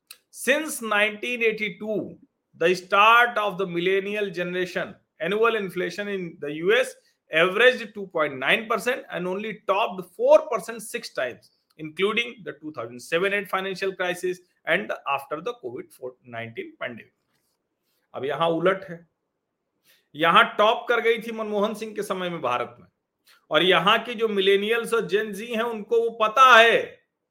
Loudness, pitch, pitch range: -23 LUFS, 205 Hz, 180-230 Hz